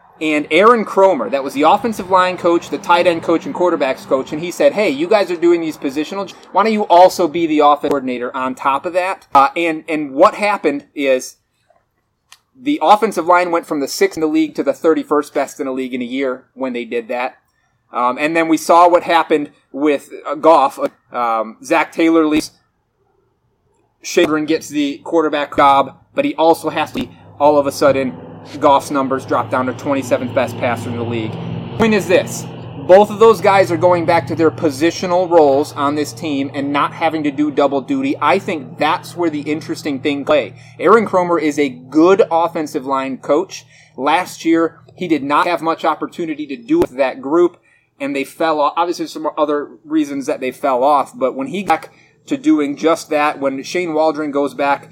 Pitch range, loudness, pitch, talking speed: 140-180 Hz, -15 LUFS, 155 Hz, 205 wpm